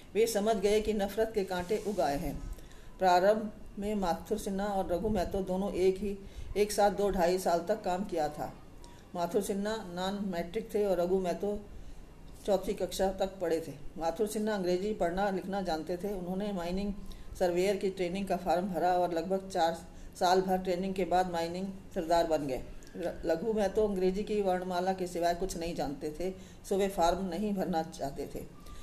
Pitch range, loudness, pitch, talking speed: 175-205 Hz, -32 LUFS, 190 Hz, 180 wpm